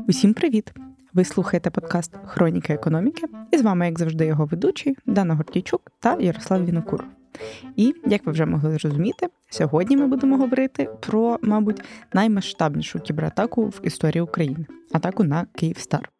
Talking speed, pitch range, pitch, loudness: 145 wpm, 160-230 Hz, 190 Hz, -22 LUFS